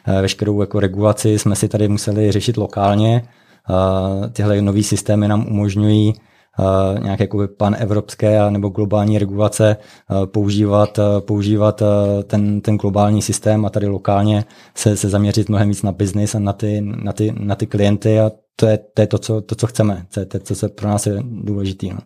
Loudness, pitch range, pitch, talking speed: -17 LUFS, 100-105 Hz, 105 Hz, 170 wpm